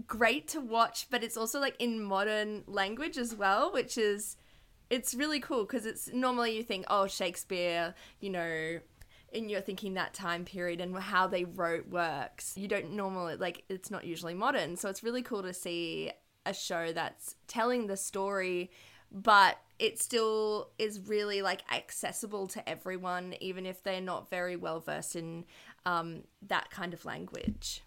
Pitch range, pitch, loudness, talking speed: 180-225 Hz, 195 Hz, -34 LUFS, 170 wpm